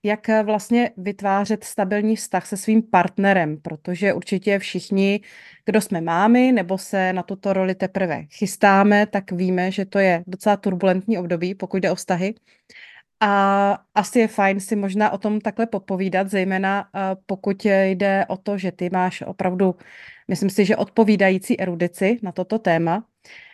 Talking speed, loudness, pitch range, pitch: 155 wpm, -21 LUFS, 185-210 Hz, 195 Hz